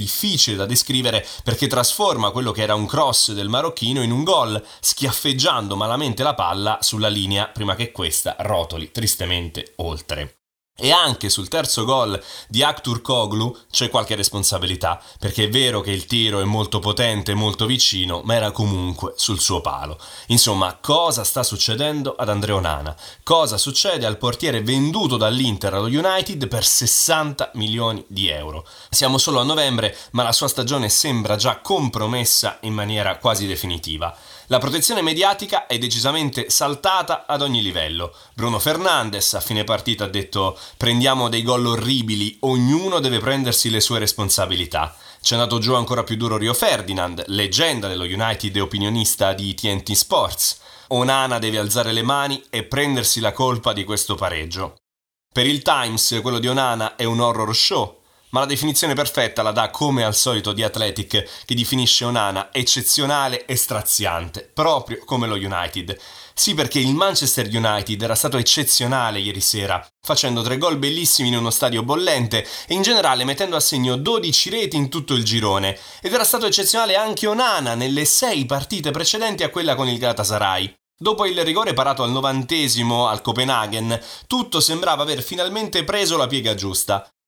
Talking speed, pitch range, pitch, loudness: 160 wpm, 105-135 Hz, 115 Hz, -19 LUFS